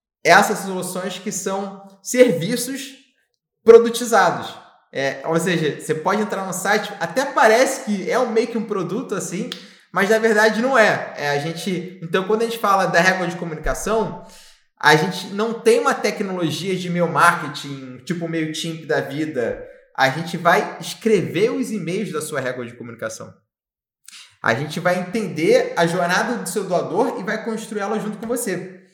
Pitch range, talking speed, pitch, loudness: 165-220 Hz, 170 wpm, 190 Hz, -19 LUFS